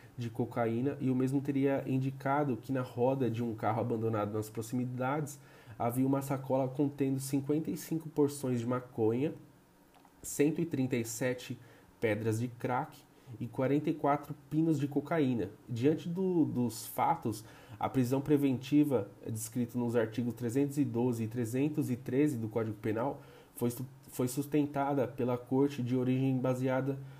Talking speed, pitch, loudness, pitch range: 125 wpm, 130 Hz, -33 LUFS, 120-145 Hz